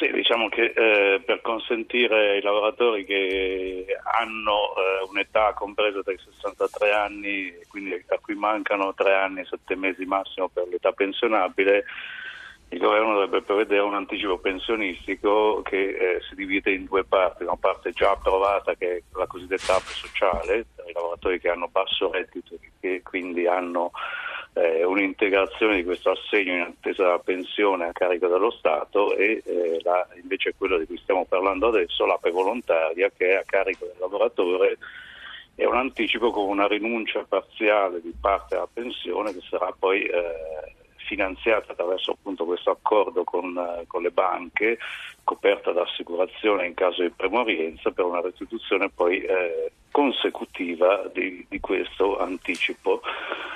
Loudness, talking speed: -24 LUFS, 155 wpm